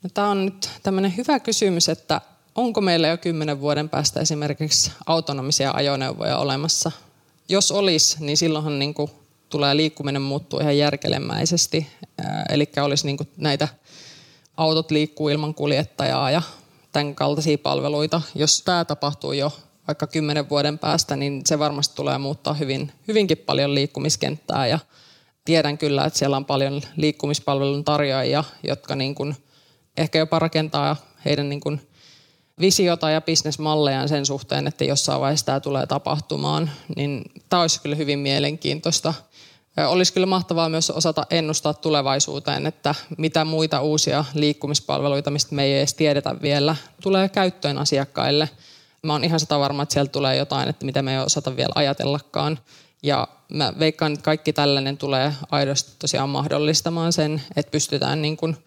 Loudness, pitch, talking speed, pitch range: -21 LUFS, 150 Hz, 145 wpm, 145-160 Hz